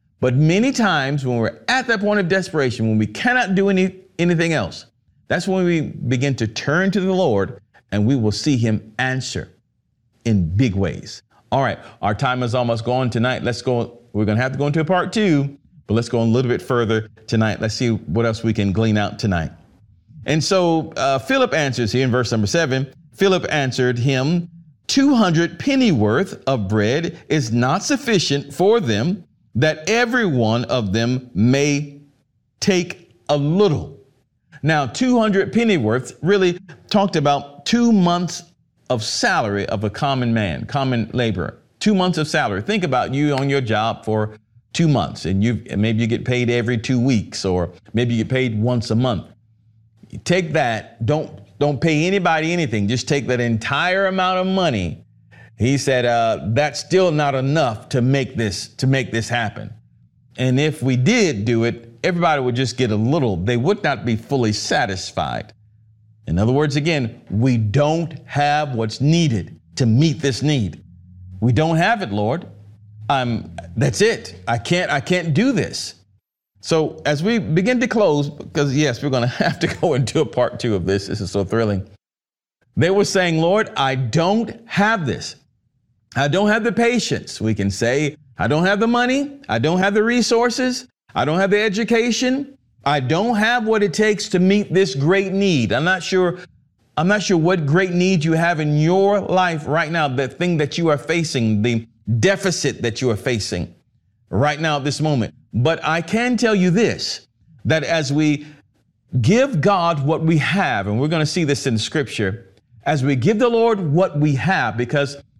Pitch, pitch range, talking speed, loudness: 140 Hz, 115-175 Hz, 185 wpm, -19 LUFS